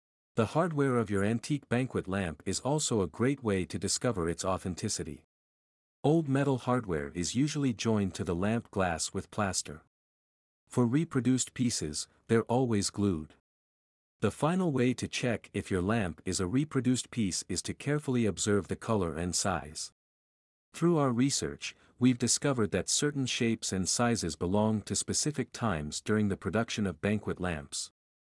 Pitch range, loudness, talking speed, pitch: 90-125 Hz, -31 LUFS, 155 wpm, 105 Hz